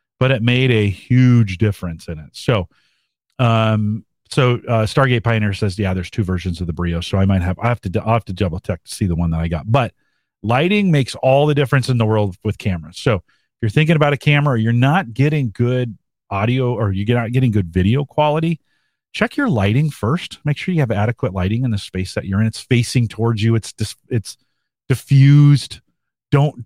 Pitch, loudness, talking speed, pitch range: 115 Hz, -17 LUFS, 215 wpm, 100-135 Hz